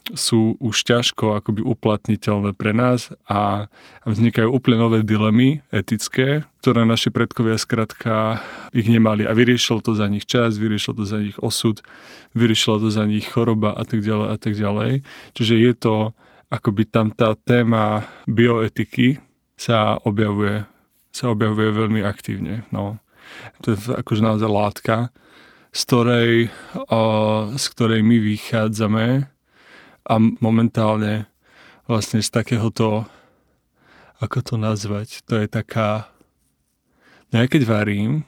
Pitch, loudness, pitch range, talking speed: 110 Hz, -19 LUFS, 105-115 Hz, 130 wpm